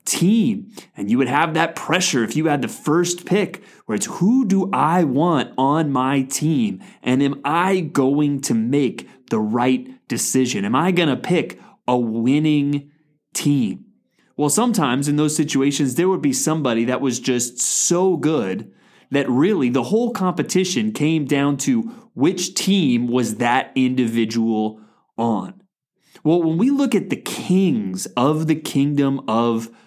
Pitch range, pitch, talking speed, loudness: 130-185 Hz, 150 Hz, 155 wpm, -19 LUFS